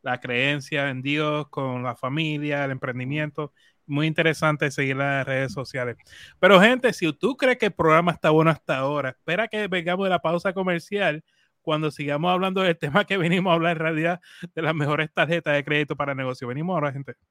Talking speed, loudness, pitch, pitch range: 200 wpm, -23 LUFS, 155 Hz, 140-175 Hz